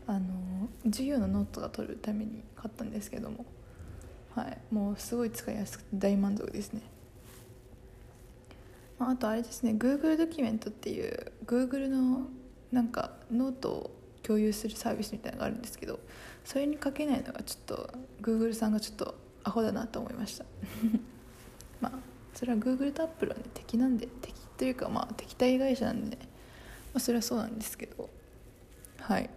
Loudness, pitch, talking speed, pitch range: -34 LUFS, 235 Hz, 385 characters per minute, 220-260 Hz